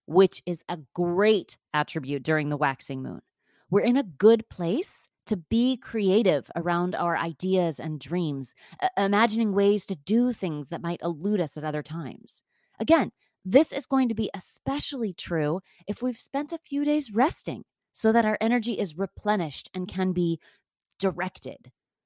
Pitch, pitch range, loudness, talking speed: 190 Hz, 170-230 Hz, -26 LUFS, 160 wpm